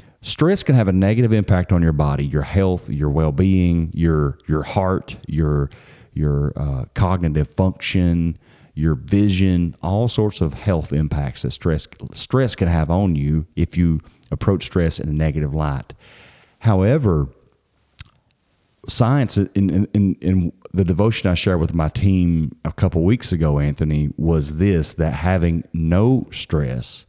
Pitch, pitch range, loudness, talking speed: 85 Hz, 75-100 Hz, -19 LUFS, 150 wpm